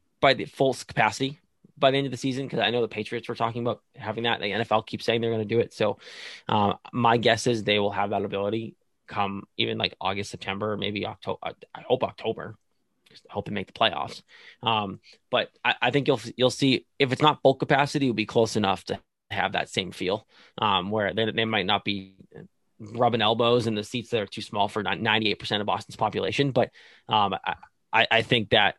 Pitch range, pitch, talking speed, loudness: 105-125 Hz, 115 Hz, 215 wpm, -26 LUFS